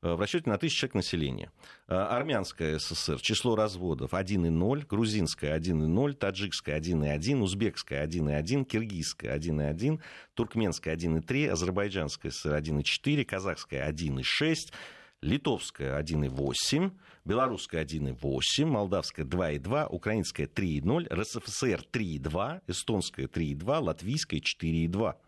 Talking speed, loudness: 95 wpm, -31 LUFS